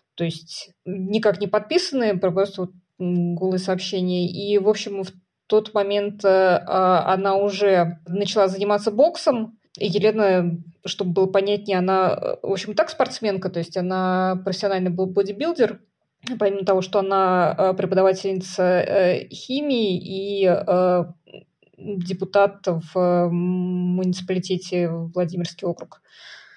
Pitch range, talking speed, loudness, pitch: 180-205 Hz, 120 wpm, -21 LUFS, 190 Hz